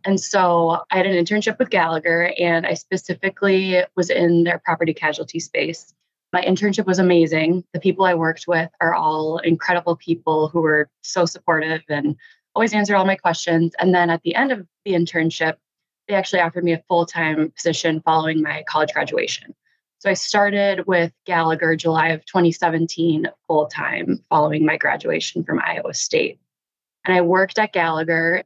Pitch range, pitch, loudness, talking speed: 165-190 Hz, 170 Hz, -19 LUFS, 165 wpm